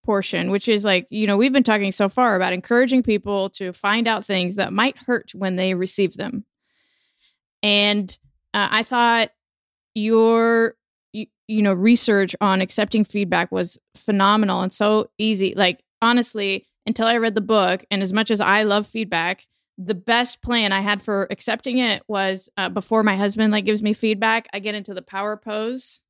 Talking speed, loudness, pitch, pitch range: 180 wpm, -20 LUFS, 210 Hz, 195-225 Hz